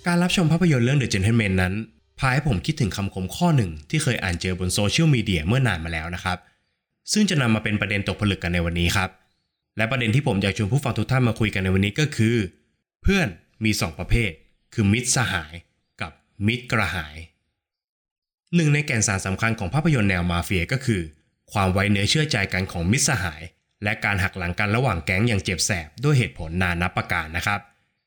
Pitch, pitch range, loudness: 105 Hz, 90-125 Hz, -22 LUFS